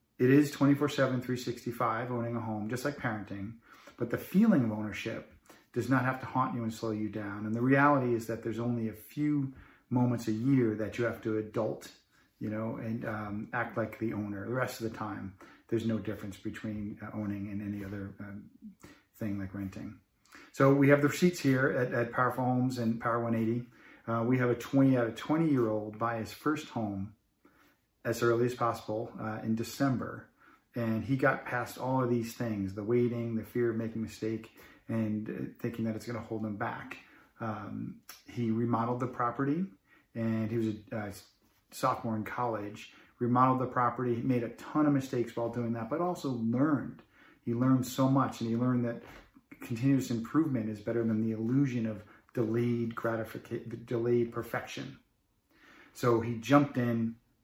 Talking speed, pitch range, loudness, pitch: 190 wpm, 110-125 Hz, -32 LUFS, 115 Hz